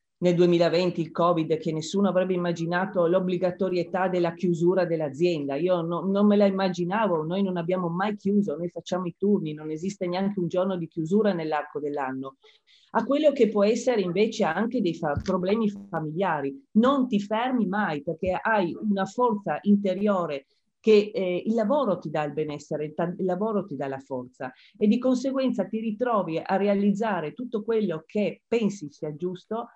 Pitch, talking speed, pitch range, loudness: 185 Hz, 170 wpm, 170-210 Hz, -26 LUFS